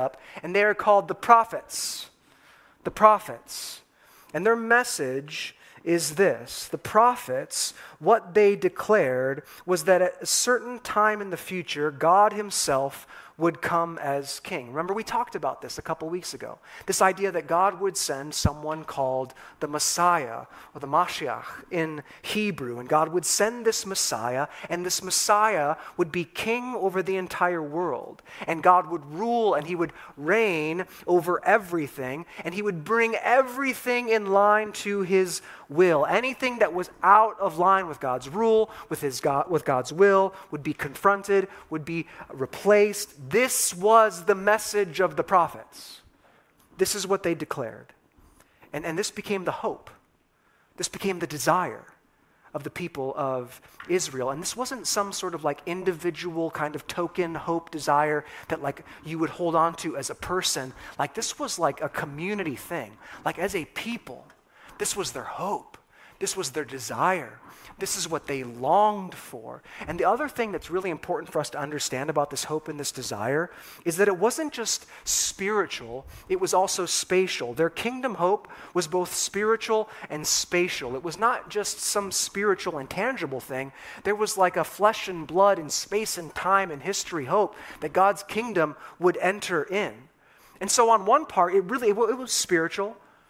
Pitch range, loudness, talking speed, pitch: 155-205 Hz, -25 LUFS, 170 wpm, 180 Hz